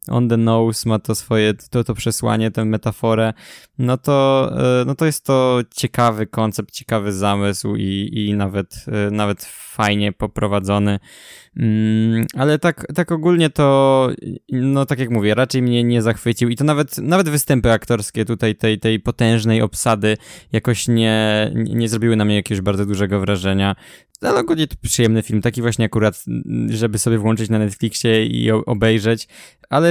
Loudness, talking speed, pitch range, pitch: -18 LUFS, 160 wpm, 110-125 Hz, 115 Hz